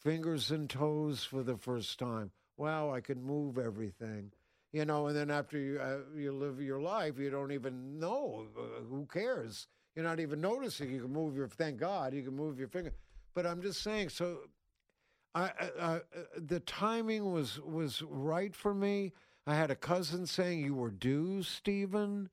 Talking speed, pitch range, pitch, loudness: 185 wpm, 135-175 Hz, 150 Hz, -38 LUFS